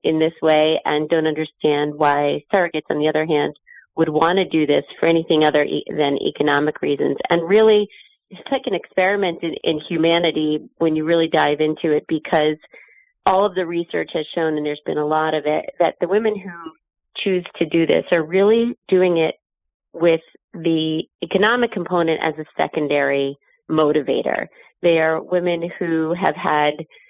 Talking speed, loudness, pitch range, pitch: 175 wpm, -19 LUFS, 155-180 Hz, 160 Hz